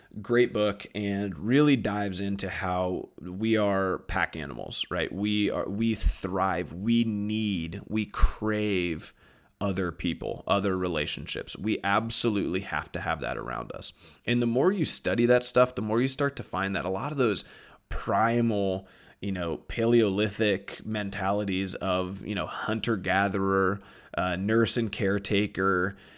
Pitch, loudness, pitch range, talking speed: 100 Hz, -28 LUFS, 95-110 Hz, 145 wpm